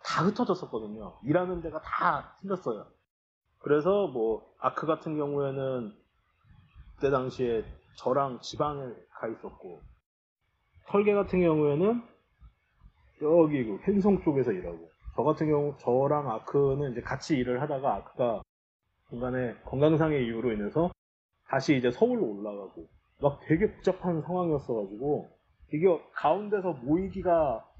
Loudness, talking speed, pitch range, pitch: -29 LUFS, 285 characters per minute, 125-175 Hz, 150 Hz